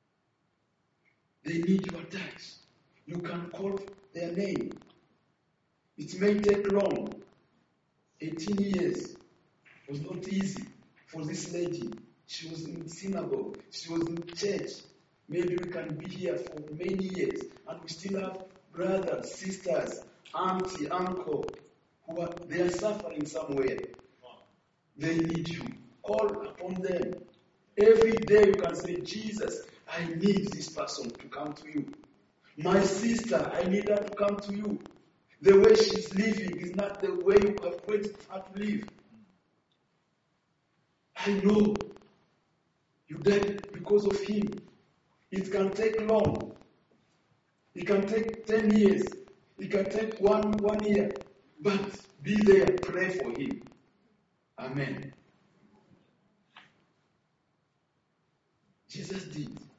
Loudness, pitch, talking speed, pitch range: -29 LUFS, 190 Hz, 125 wpm, 170-205 Hz